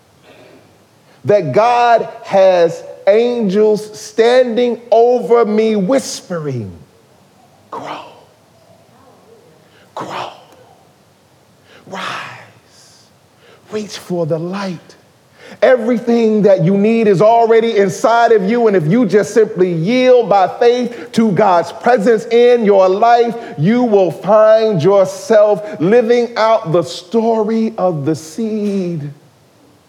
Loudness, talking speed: -12 LUFS, 100 wpm